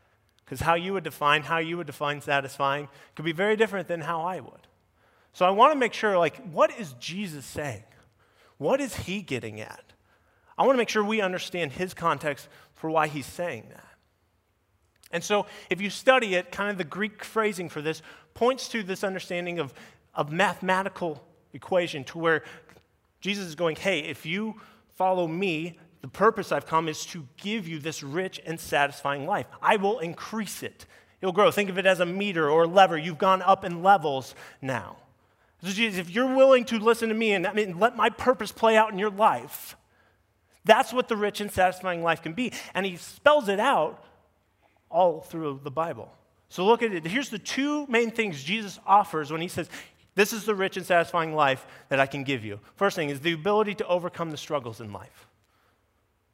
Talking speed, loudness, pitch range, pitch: 200 wpm, -26 LUFS, 150-205 Hz, 180 Hz